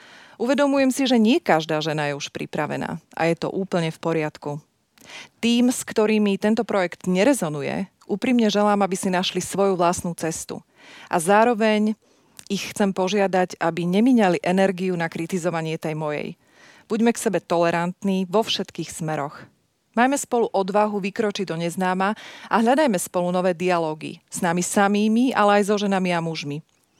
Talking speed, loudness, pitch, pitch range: 150 wpm, -22 LUFS, 190 Hz, 170-215 Hz